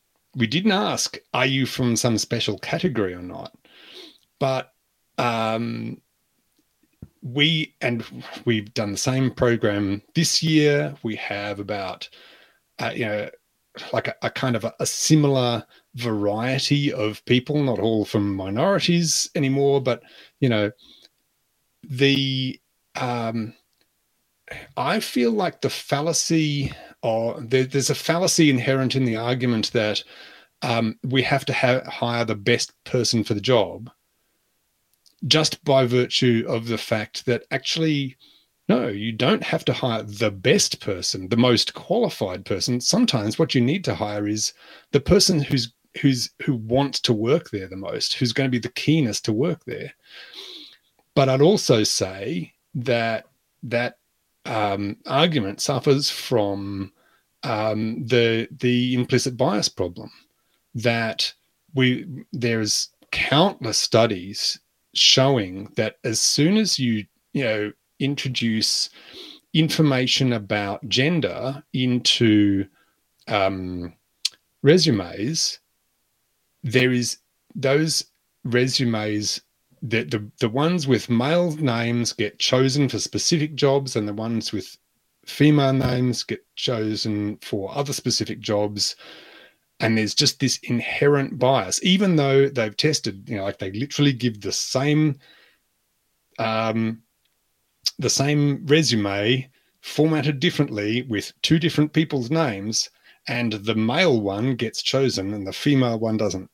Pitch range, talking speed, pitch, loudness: 110-140 Hz, 130 wpm, 125 Hz, -22 LUFS